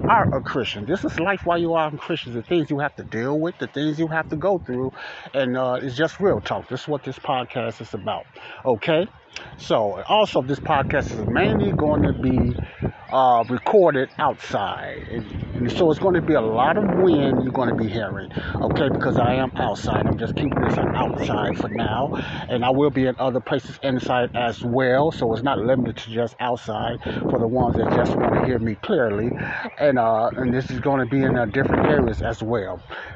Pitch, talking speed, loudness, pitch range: 130 Hz, 215 wpm, -22 LUFS, 120-150 Hz